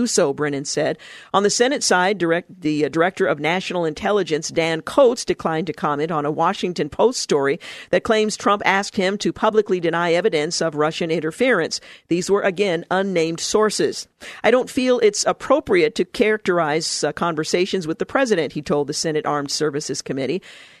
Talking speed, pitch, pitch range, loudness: 175 wpm, 175 Hz, 160-205 Hz, -20 LUFS